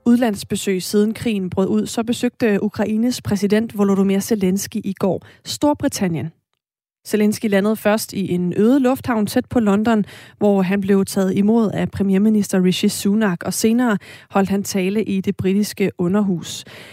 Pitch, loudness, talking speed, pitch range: 205 Hz, -19 LUFS, 150 wpm, 195-220 Hz